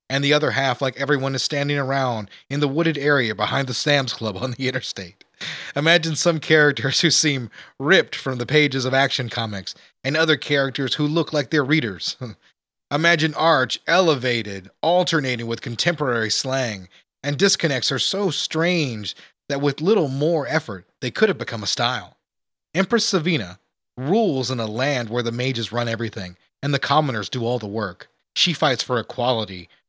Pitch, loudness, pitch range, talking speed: 135 Hz, -21 LUFS, 120-155 Hz, 170 wpm